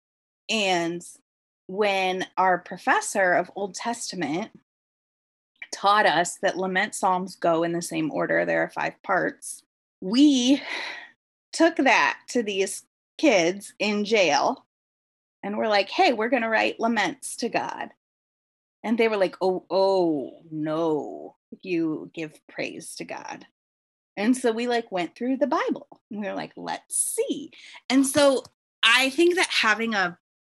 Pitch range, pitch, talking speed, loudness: 180-255 Hz, 205 Hz, 145 wpm, -24 LUFS